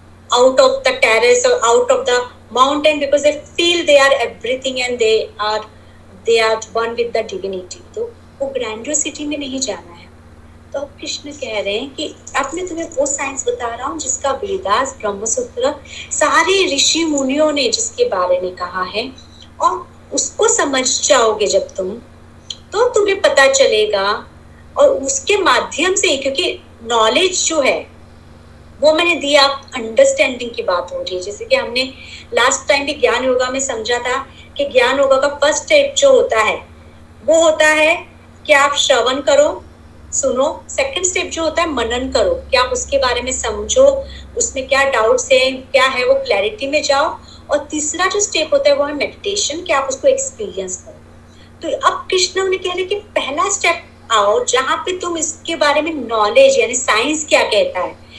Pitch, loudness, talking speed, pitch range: 290 Hz, -15 LUFS, 155 wpm, 260-355 Hz